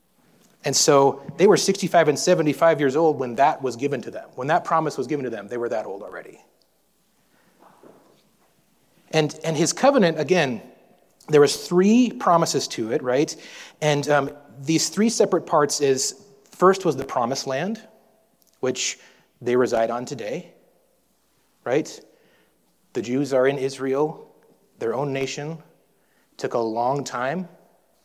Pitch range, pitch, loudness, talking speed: 135-180 Hz, 150 Hz, -22 LUFS, 150 wpm